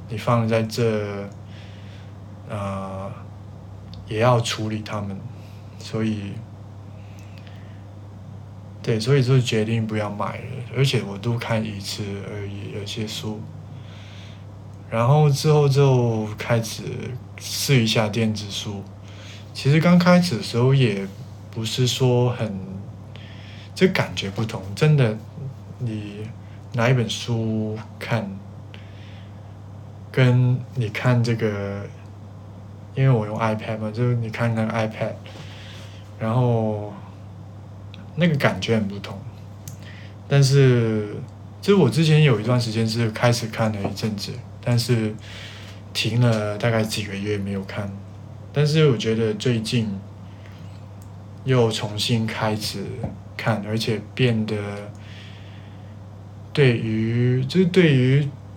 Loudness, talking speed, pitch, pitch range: -22 LUFS, 165 characters per minute, 105 Hz, 100-115 Hz